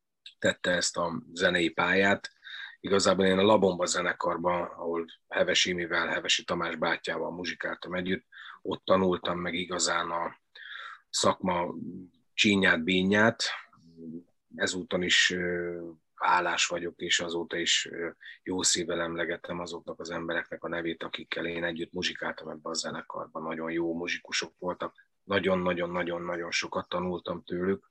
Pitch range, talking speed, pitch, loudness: 85-90 Hz, 120 wpm, 85 Hz, -29 LUFS